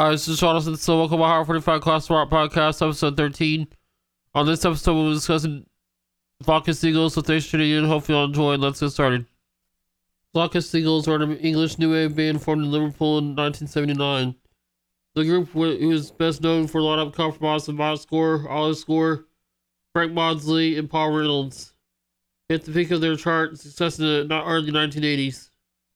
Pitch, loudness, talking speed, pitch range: 155 Hz, -22 LUFS, 190 wpm, 145-160 Hz